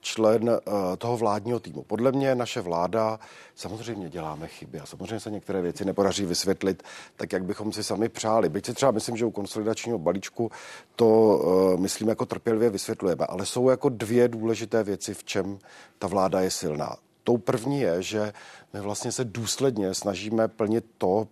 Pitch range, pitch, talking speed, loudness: 100-115 Hz, 110 Hz, 175 wpm, -26 LUFS